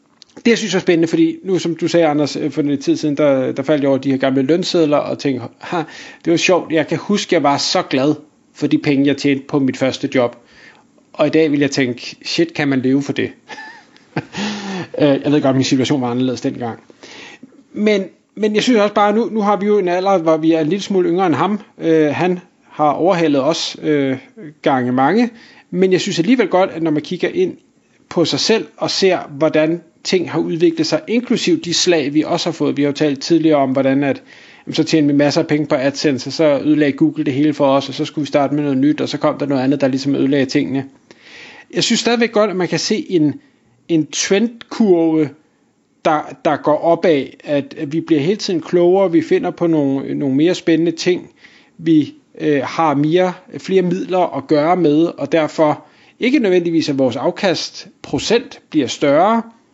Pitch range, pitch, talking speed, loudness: 145-185 Hz, 160 Hz, 215 wpm, -16 LUFS